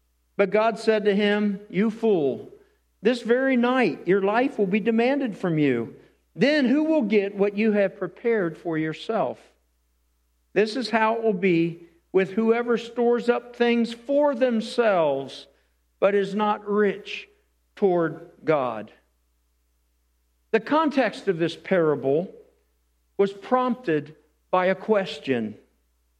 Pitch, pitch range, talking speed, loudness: 200 Hz, 155-235 Hz, 130 wpm, -23 LUFS